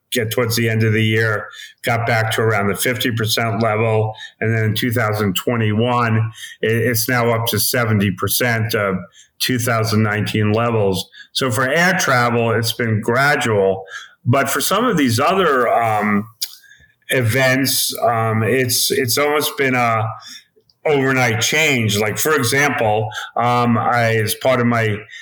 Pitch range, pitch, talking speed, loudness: 110-125 Hz, 115 Hz, 155 wpm, -17 LUFS